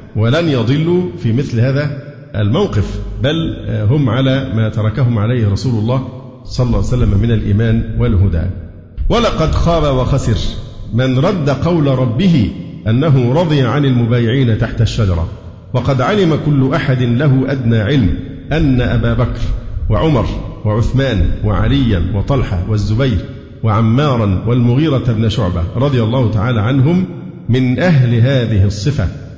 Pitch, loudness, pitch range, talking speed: 120 Hz, -14 LUFS, 110-135 Hz, 125 wpm